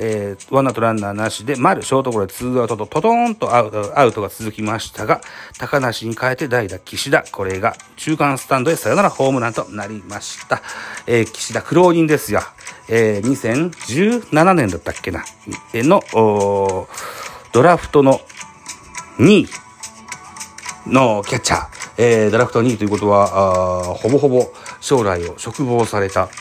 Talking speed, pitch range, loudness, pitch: 315 characters per minute, 105-135 Hz, -17 LUFS, 115 Hz